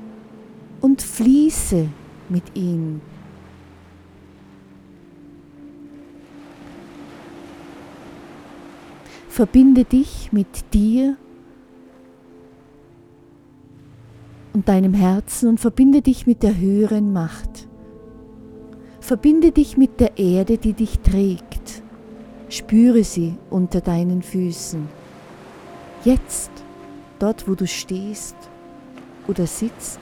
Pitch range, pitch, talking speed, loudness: 175-235 Hz, 210 Hz, 75 wpm, -18 LUFS